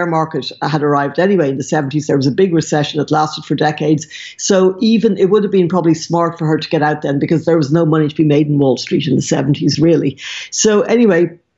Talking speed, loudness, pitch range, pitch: 245 wpm, -14 LUFS, 145-170 Hz, 155 Hz